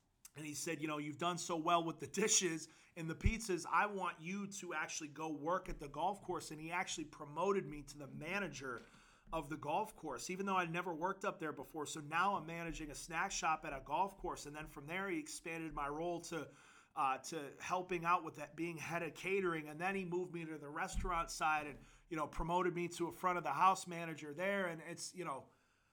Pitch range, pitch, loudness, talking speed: 155-180 Hz, 165 Hz, -41 LUFS, 235 wpm